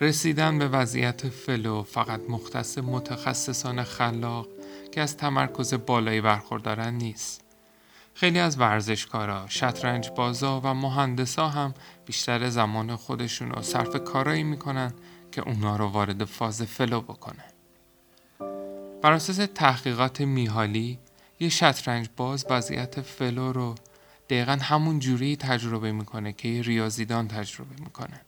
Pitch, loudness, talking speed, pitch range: 125 Hz, -27 LUFS, 115 wpm, 110-140 Hz